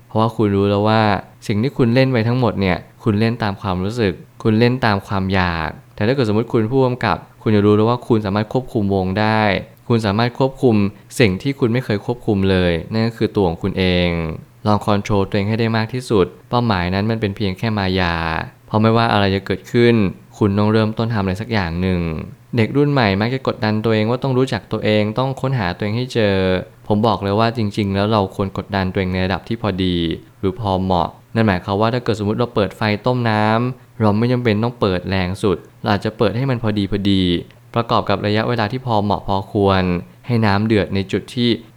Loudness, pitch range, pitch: -18 LUFS, 95-115 Hz, 105 Hz